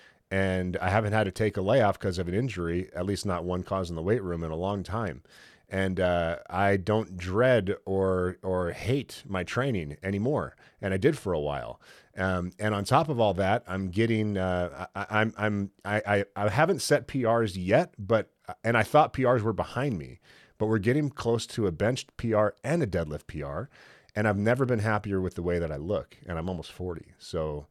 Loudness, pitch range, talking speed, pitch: -28 LUFS, 90-115 Hz, 210 wpm, 100 Hz